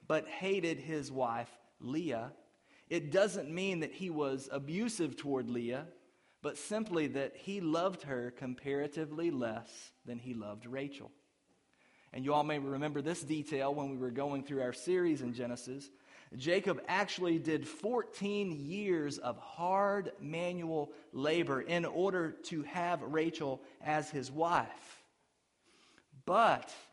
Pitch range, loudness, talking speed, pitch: 135-175 Hz, -36 LUFS, 135 wpm, 155 Hz